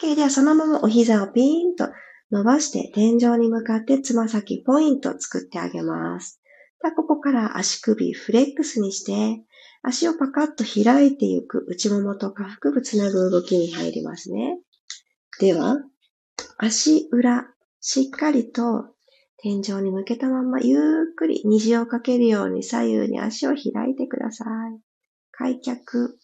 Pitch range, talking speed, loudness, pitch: 215-275 Hz, 285 characters per minute, -21 LUFS, 240 Hz